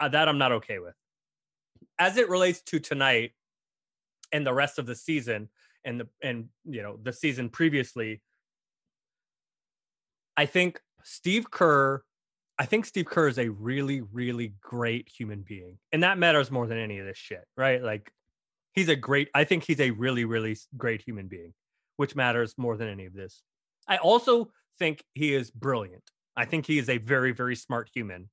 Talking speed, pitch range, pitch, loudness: 180 wpm, 115-155 Hz, 130 Hz, -27 LUFS